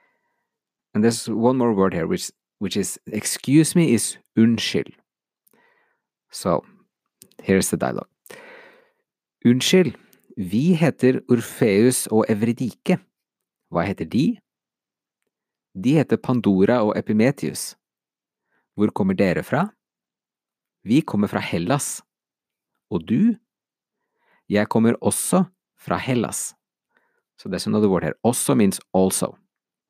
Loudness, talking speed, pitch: -21 LUFS, 120 wpm, 130 Hz